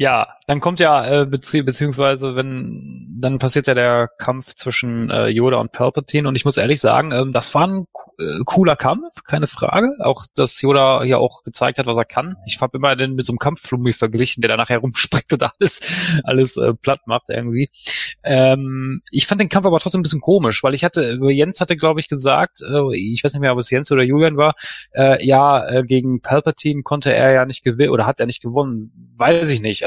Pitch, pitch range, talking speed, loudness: 135 Hz, 125-145 Hz, 220 wpm, -17 LUFS